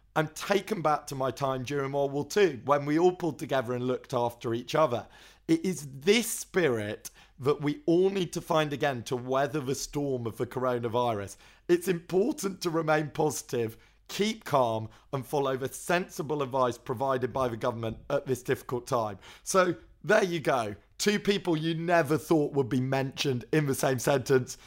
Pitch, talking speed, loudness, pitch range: 140 Hz, 180 wpm, -29 LUFS, 130-165 Hz